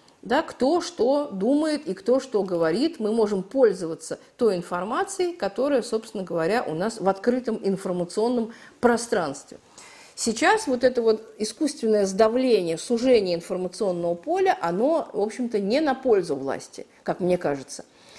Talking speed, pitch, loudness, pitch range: 135 wpm, 225 Hz, -24 LUFS, 190-265 Hz